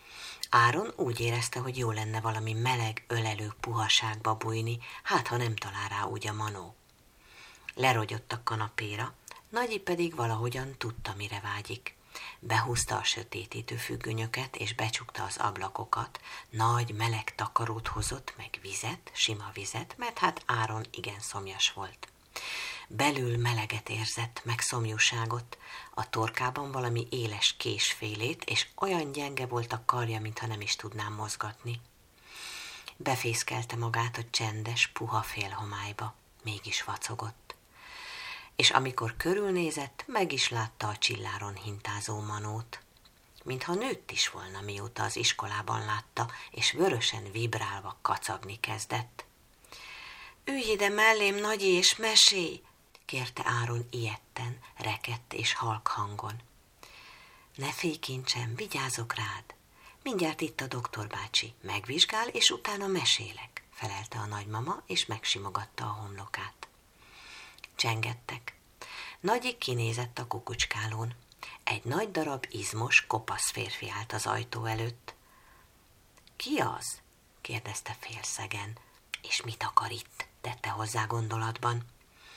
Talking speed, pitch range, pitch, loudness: 120 wpm, 110-125 Hz, 115 Hz, -31 LUFS